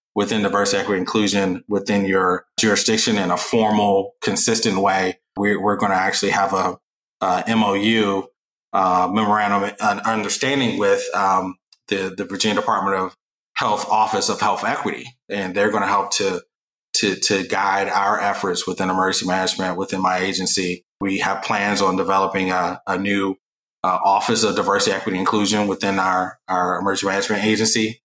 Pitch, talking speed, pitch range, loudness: 100 Hz, 155 wpm, 95-105 Hz, -19 LUFS